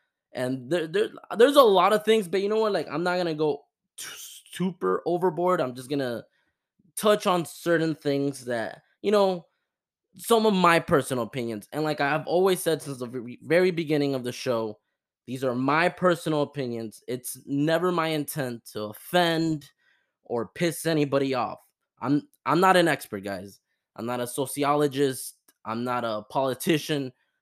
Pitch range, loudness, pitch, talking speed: 130-175 Hz, -25 LUFS, 145 Hz, 175 wpm